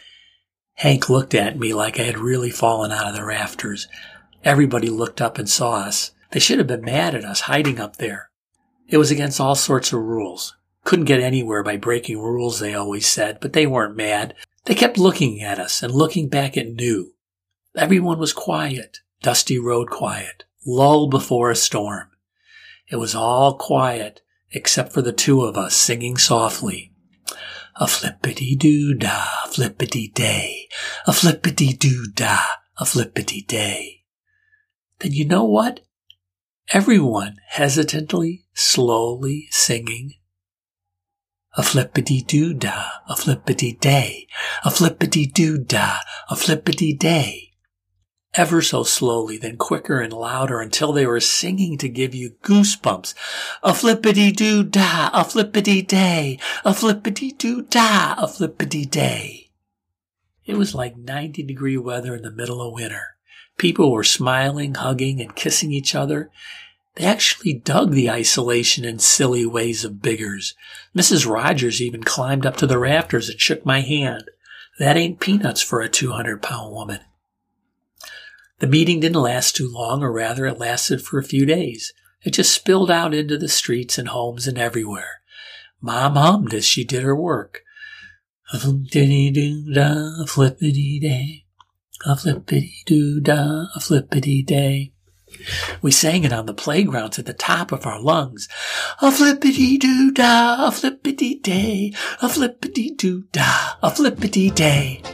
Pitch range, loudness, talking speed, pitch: 120-170 Hz, -18 LUFS, 150 wpm, 140 Hz